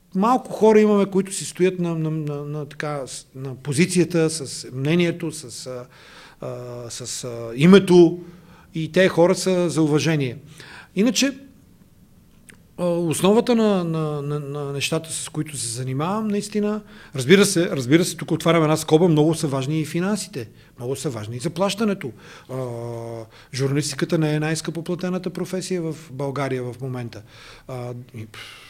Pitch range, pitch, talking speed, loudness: 135-180 Hz, 155 Hz, 135 wpm, -21 LUFS